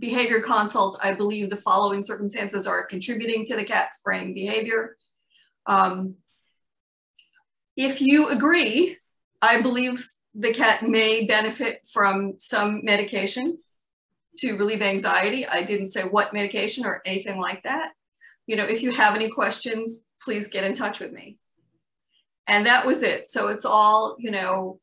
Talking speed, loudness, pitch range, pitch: 145 wpm, -23 LUFS, 200-240 Hz, 215 Hz